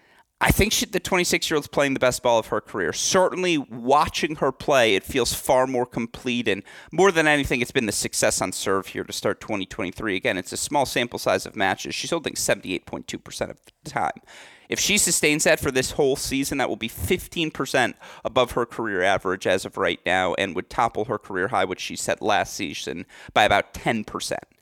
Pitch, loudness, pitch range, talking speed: 150 Hz, -23 LUFS, 130-180 Hz, 200 wpm